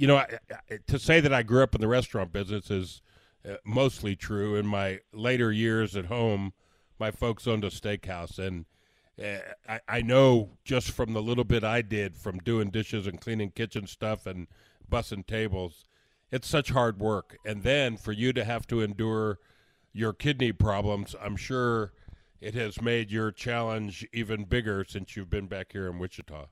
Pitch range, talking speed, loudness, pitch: 100-120 Hz, 185 wpm, -29 LUFS, 110 Hz